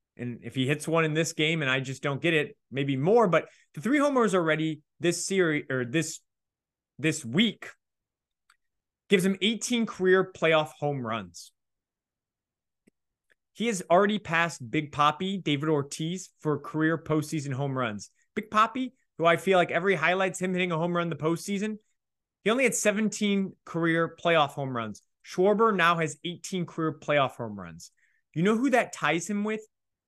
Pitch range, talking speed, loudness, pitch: 145-195 Hz, 170 wpm, -27 LUFS, 165 Hz